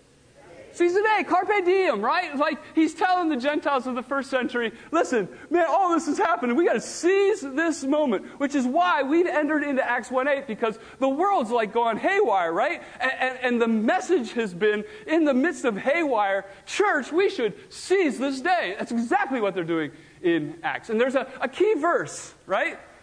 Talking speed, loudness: 190 wpm, -24 LUFS